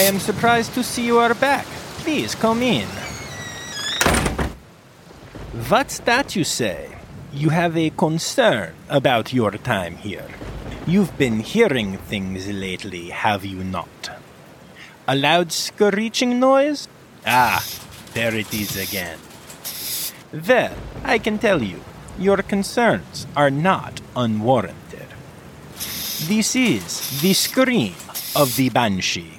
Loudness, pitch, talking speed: -20 LUFS, 160 Hz, 120 wpm